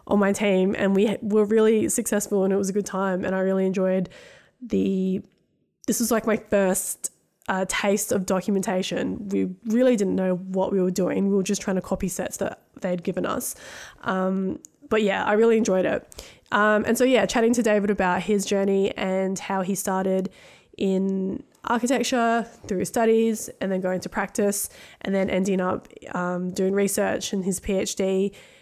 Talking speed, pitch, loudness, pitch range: 180 wpm, 195 Hz, -24 LUFS, 190-215 Hz